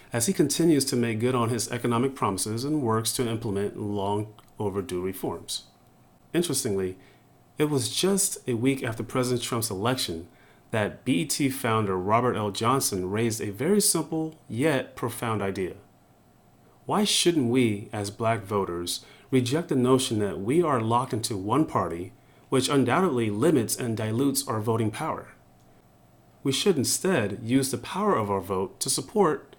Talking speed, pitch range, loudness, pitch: 150 wpm, 105-135 Hz, -26 LUFS, 120 Hz